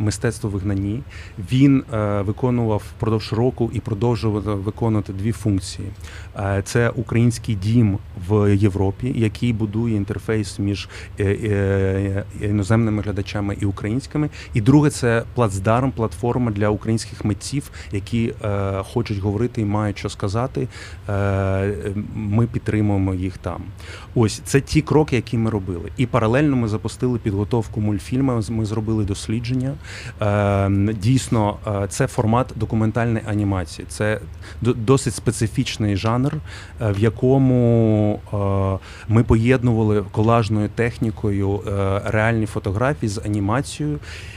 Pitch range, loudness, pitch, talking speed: 100-120 Hz, -21 LUFS, 110 Hz, 115 wpm